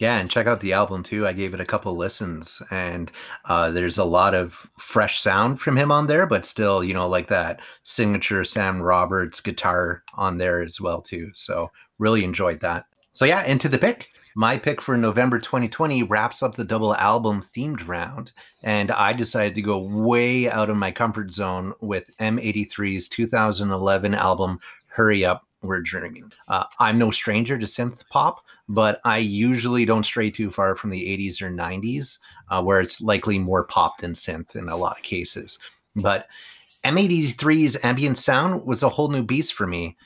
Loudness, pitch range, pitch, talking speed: -22 LUFS, 95-120 Hz, 105 Hz, 185 wpm